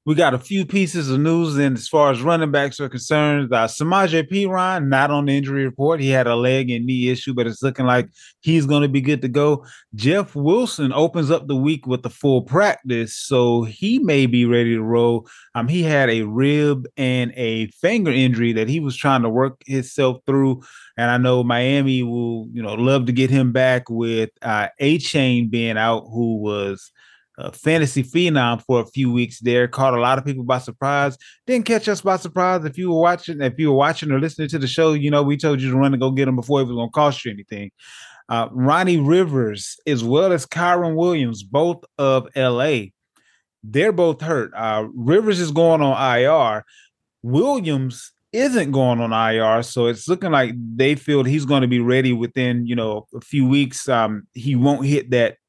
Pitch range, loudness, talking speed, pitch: 120-150 Hz, -19 LUFS, 210 wpm, 135 Hz